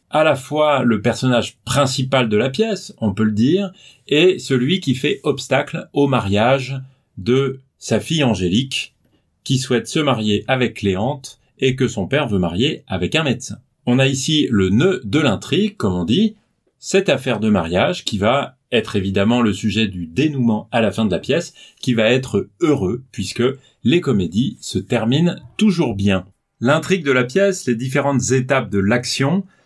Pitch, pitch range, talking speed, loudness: 130 Hz, 110-145 Hz, 175 wpm, -18 LUFS